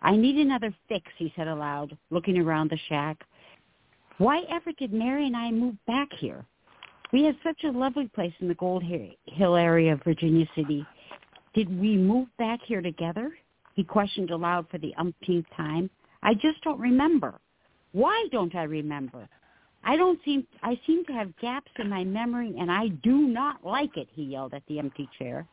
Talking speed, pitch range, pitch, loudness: 185 wpm, 160-255 Hz, 195 Hz, -27 LUFS